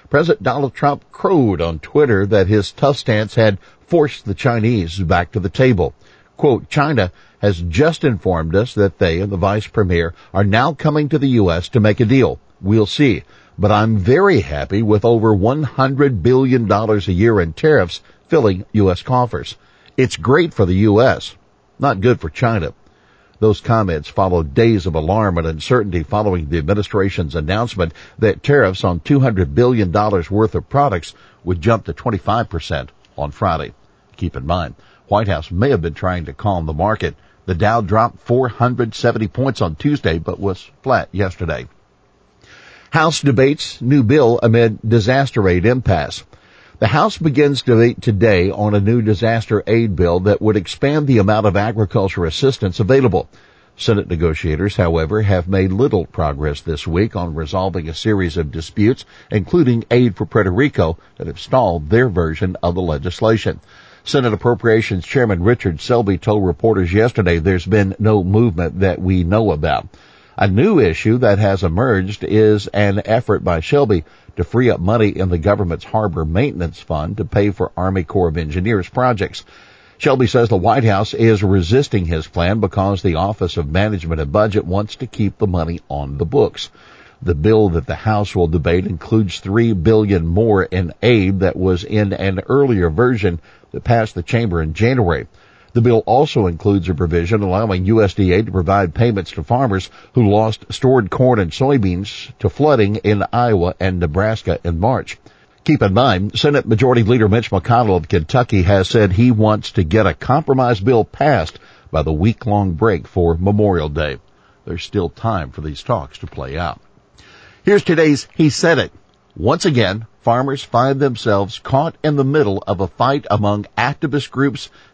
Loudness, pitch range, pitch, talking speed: -16 LUFS, 90-120 Hz, 105 Hz, 170 wpm